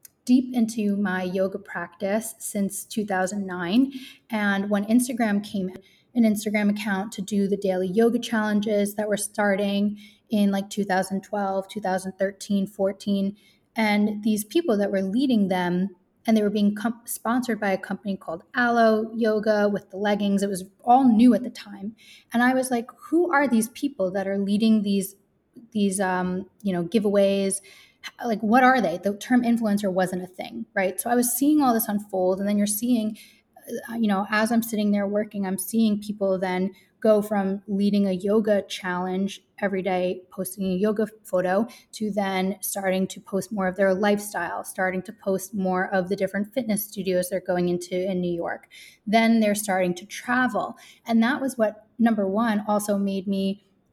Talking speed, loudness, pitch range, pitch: 175 wpm, -24 LUFS, 195-220 Hz, 205 Hz